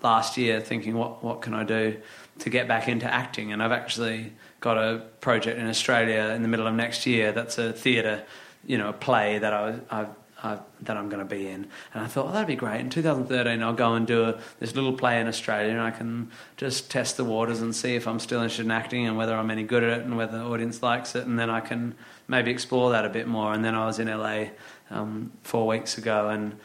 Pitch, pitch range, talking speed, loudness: 115 Hz, 110-120 Hz, 250 wpm, -27 LUFS